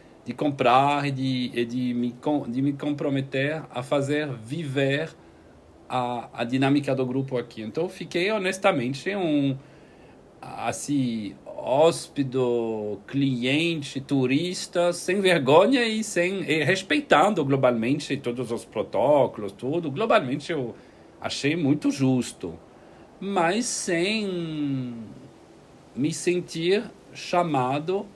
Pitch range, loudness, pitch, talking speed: 125-170 Hz, -25 LUFS, 140 Hz, 100 wpm